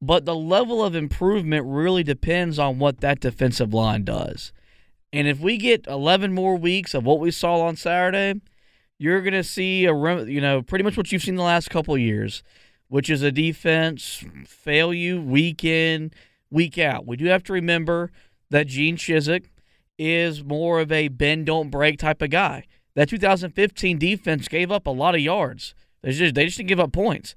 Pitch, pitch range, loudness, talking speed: 160 Hz, 145-180 Hz, -21 LUFS, 190 wpm